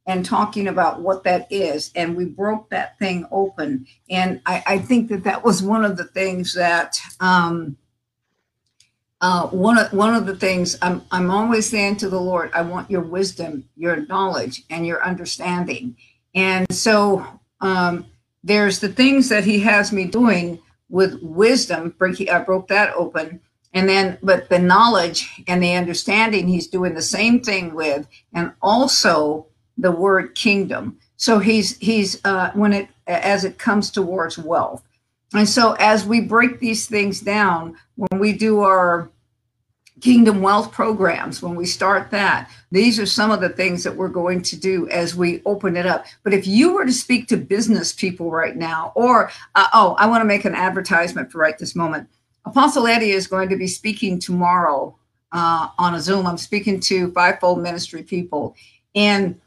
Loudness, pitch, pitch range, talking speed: -18 LUFS, 185 Hz, 175-205 Hz, 175 wpm